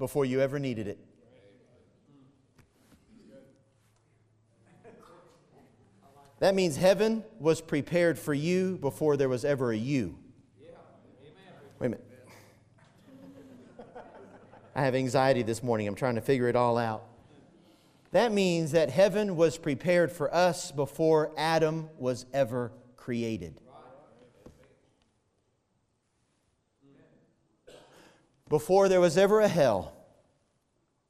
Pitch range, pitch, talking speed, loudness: 120-160 Hz, 135 Hz, 100 wpm, -28 LUFS